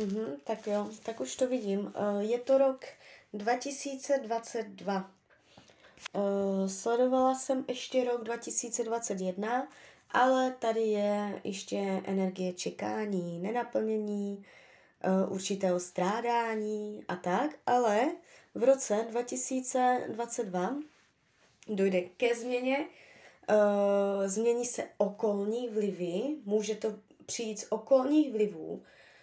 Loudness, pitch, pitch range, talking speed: -31 LUFS, 220 Hz, 200-245 Hz, 90 wpm